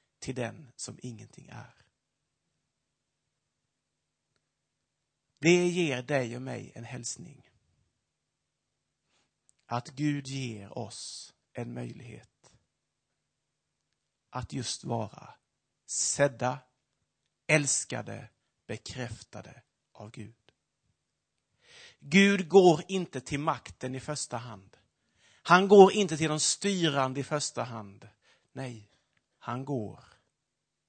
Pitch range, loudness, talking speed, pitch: 115-150 Hz, -28 LUFS, 90 wpm, 130 Hz